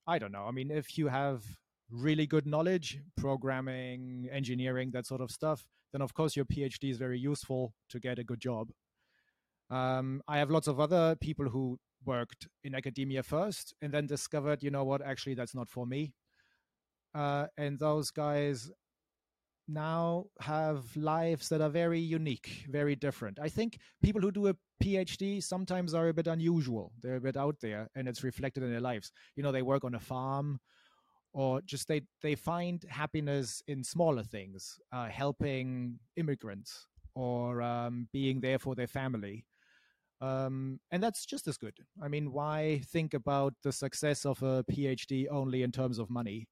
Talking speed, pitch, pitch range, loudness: 175 wpm, 135 Hz, 125-150 Hz, -35 LUFS